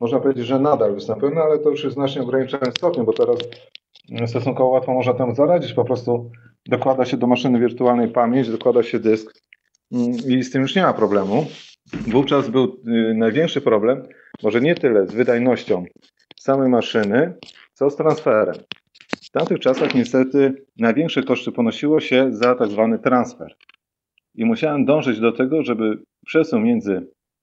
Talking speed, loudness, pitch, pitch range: 160 wpm, -19 LUFS, 130 Hz, 120-140 Hz